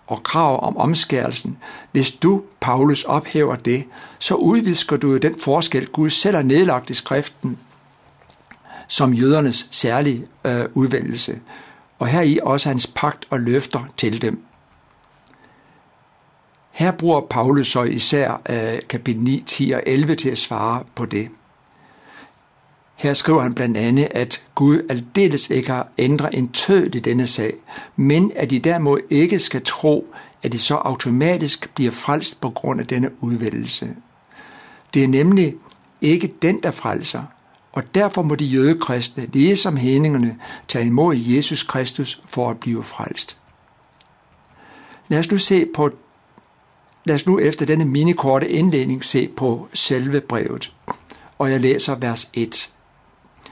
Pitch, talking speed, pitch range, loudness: 135 Hz, 145 wpm, 125-155 Hz, -19 LUFS